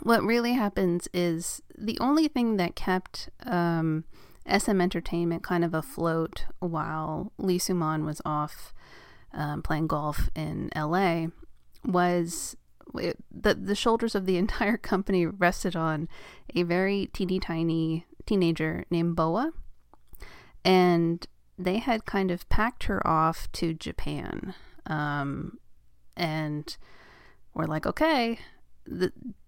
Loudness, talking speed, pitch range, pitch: -28 LUFS, 120 wpm, 160-200 Hz, 175 Hz